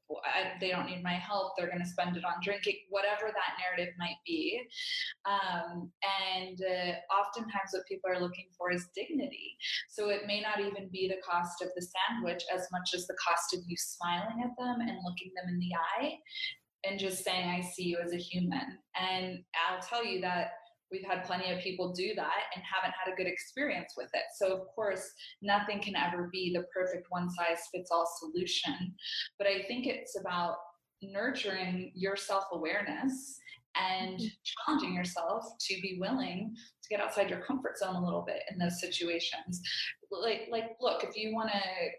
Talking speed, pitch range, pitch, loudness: 185 wpm, 180-210 Hz, 190 Hz, -35 LUFS